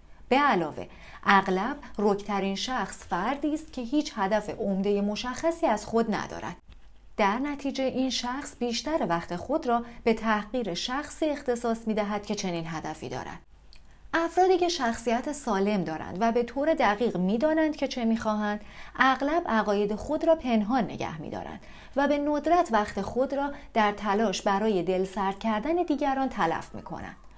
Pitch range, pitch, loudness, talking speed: 205-280 Hz, 230 Hz, -27 LUFS, 155 wpm